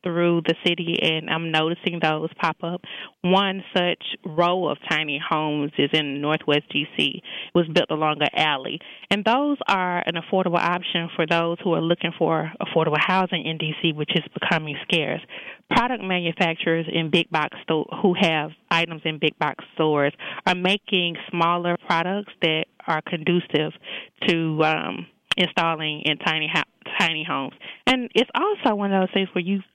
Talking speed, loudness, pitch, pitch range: 165 wpm, -23 LUFS, 170 Hz, 160-185 Hz